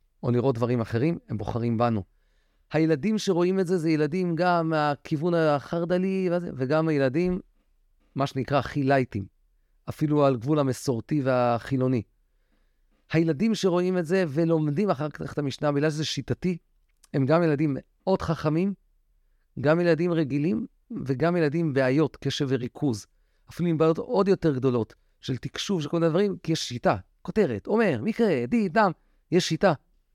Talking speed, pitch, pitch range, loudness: 145 wpm, 155 Hz, 135-175 Hz, -25 LUFS